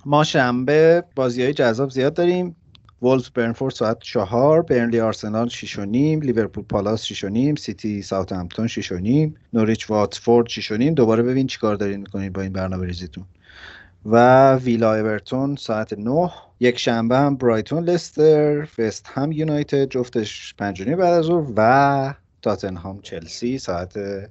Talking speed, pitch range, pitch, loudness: 155 wpm, 105-140 Hz, 115 Hz, -20 LUFS